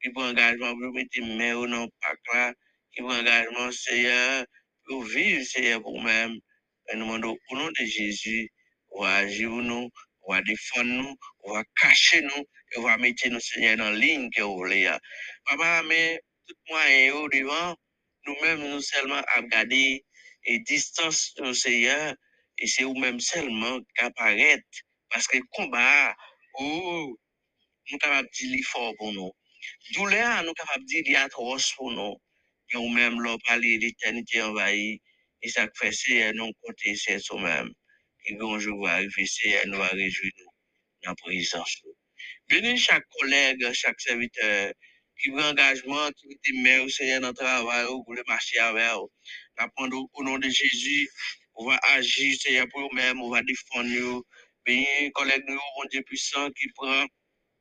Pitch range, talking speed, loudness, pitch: 115-140 Hz, 180 wpm, -24 LUFS, 125 Hz